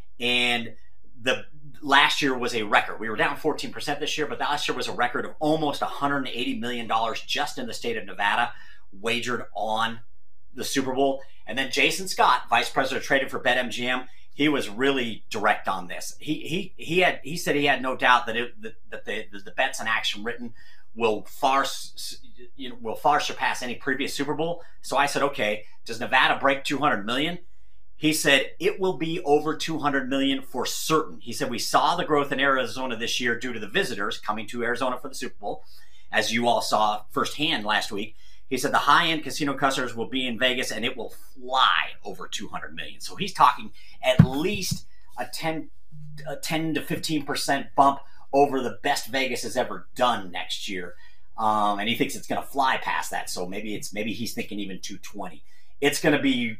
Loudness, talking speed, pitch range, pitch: -25 LUFS, 205 wpm, 120-150 Hz, 135 Hz